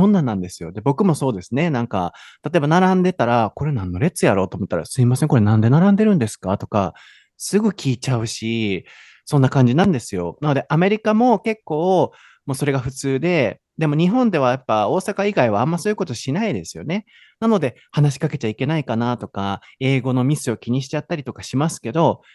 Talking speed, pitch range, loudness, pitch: 450 characters per minute, 115-175 Hz, -19 LUFS, 135 Hz